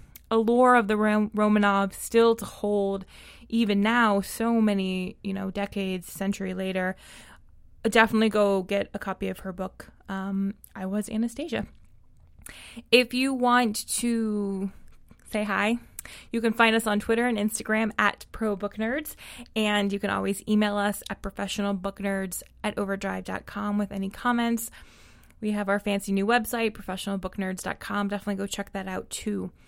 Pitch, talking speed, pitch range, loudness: 205 Hz, 145 wpm, 195-225 Hz, -26 LUFS